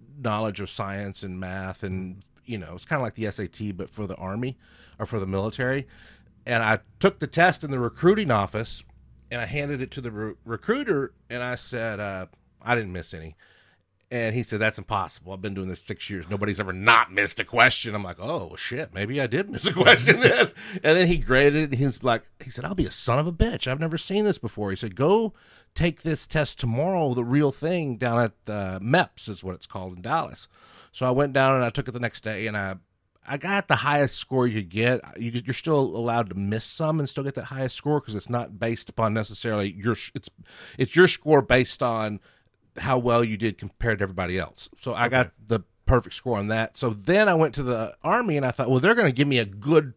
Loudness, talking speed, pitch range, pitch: -24 LUFS, 235 wpm, 100-135 Hz, 115 Hz